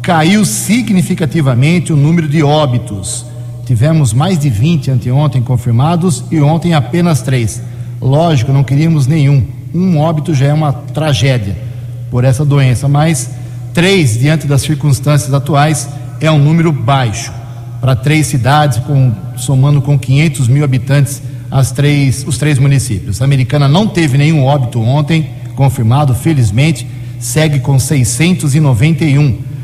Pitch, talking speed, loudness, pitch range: 140 Hz, 130 wpm, -11 LUFS, 125-155 Hz